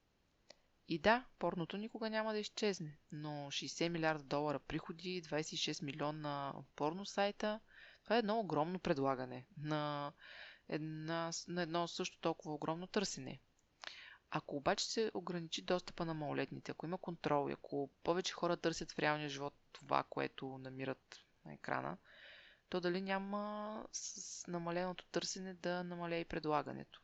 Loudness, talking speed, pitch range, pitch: -41 LUFS, 140 wpm, 150-185 Hz, 170 Hz